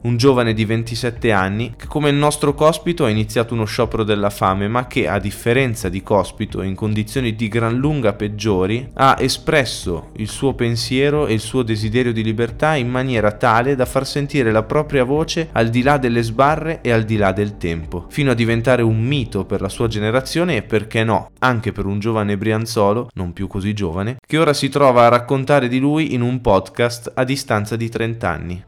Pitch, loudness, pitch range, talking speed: 115 Hz, -18 LUFS, 105-130 Hz, 200 wpm